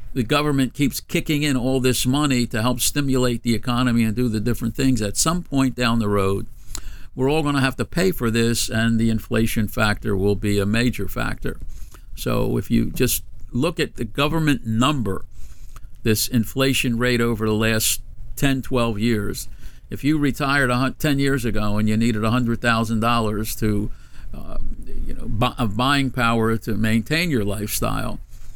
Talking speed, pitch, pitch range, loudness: 175 wpm, 120 Hz, 110-130 Hz, -21 LUFS